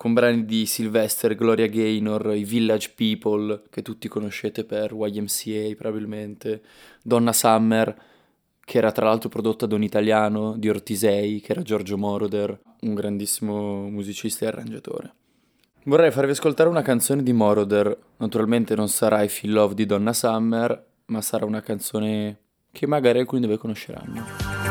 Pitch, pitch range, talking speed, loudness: 110 Hz, 105-115 Hz, 150 wpm, -23 LUFS